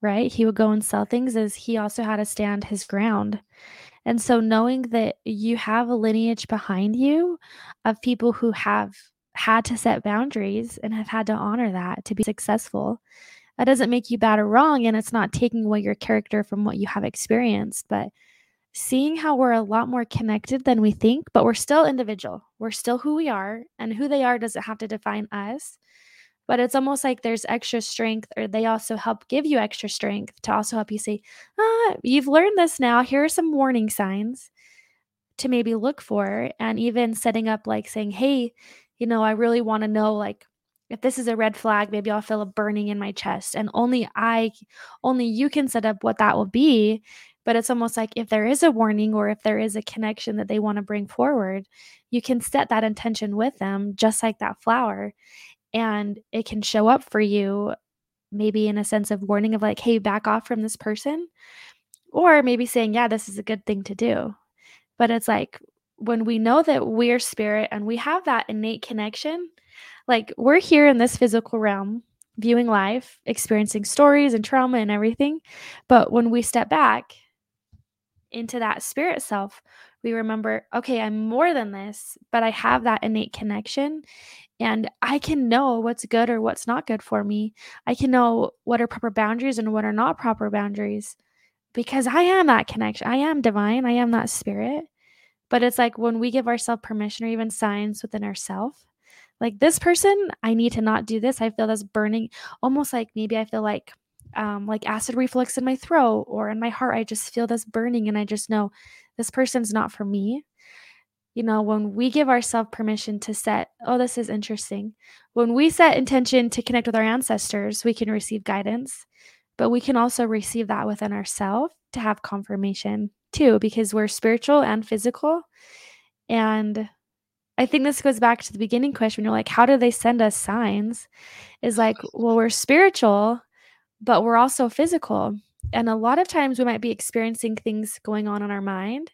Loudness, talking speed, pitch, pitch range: -22 LUFS, 200 wpm, 230 Hz, 215-245 Hz